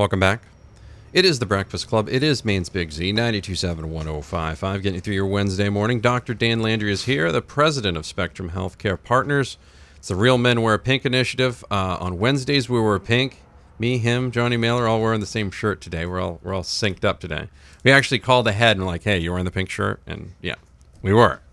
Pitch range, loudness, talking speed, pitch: 90-120 Hz, -21 LUFS, 215 wpm, 105 Hz